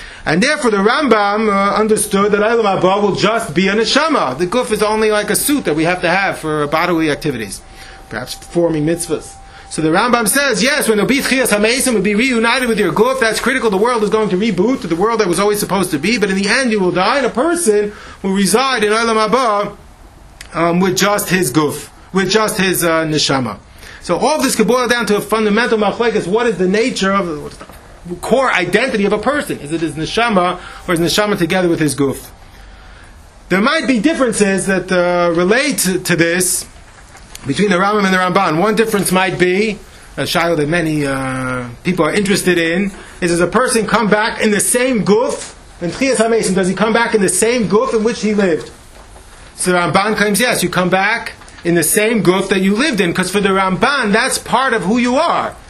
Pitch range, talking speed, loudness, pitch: 170-220 Hz, 210 wpm, -14 LUFS, 195 Hz